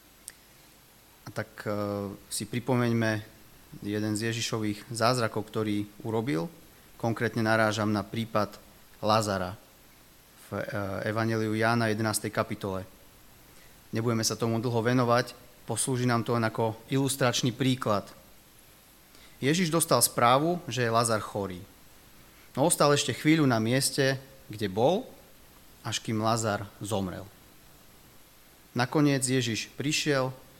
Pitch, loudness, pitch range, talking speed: 115 Hz, -28 LUFS, 105-125 Hz, 105 wpm